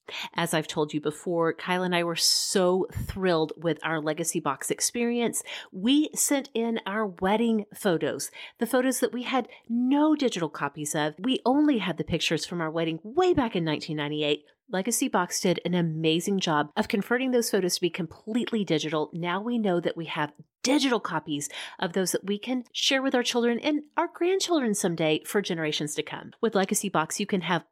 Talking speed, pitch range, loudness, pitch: 190 wpm, 160-240 Hz, -27 LUFS, 185 Hz